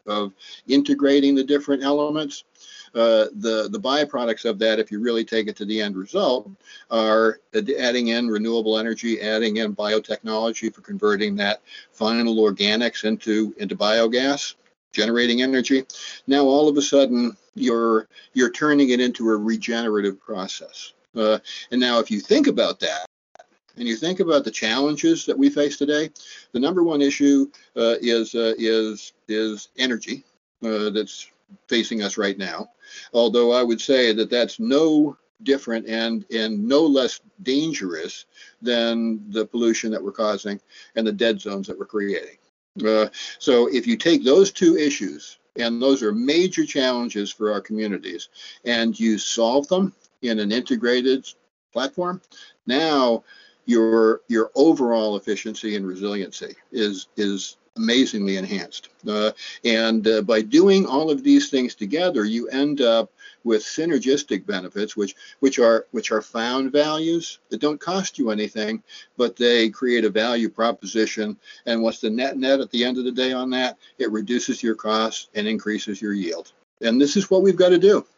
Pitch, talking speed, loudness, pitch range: 115 Hz, 160 wpm, -21 LUFS, 110-140 Hz